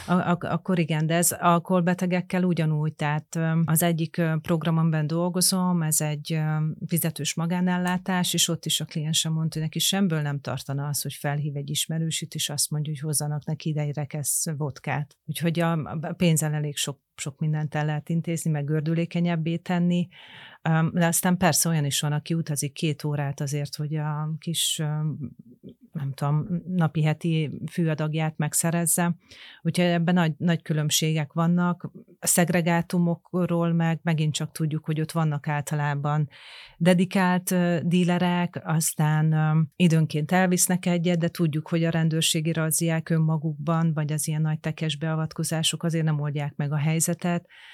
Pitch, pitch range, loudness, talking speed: 160 Hz, 155-170 Hz, -25 LUFS, 145 wpm